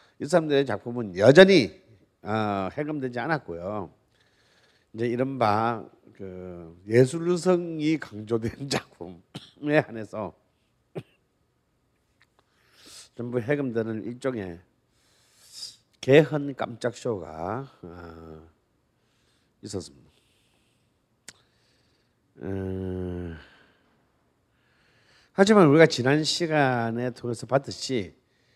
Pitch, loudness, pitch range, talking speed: 120 Hz, -24 LUFS, 100-140 Hz, 145 characters per minute